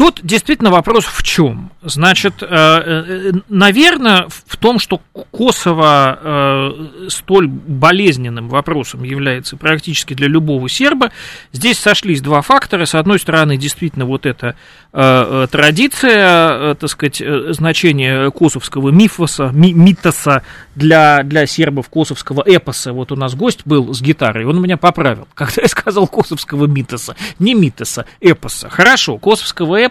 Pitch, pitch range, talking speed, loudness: 160 Hz, 140-185 Hz, 125 wpm, -12 LUFS